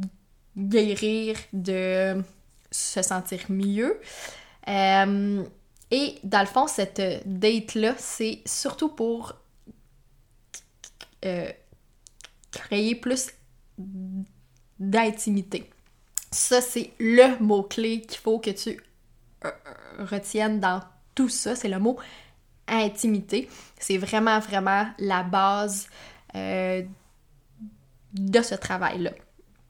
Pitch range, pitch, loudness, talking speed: 190-225 Hz, 205 Hz, -25 LUFS, 90 wpm